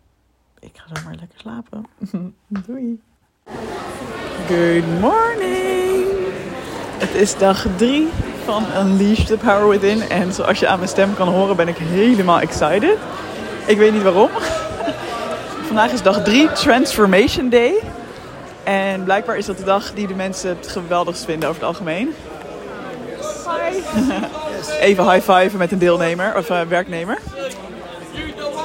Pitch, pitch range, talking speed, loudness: 200 Hz, 185-235 Hz, 130 wpm, -17 LUFS